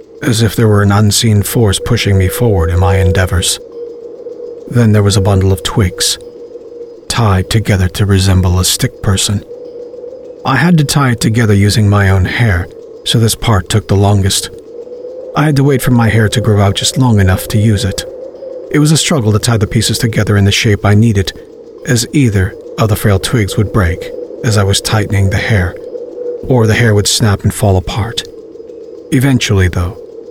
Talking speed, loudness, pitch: 190 wpm, -11 LUFS, 115 Hz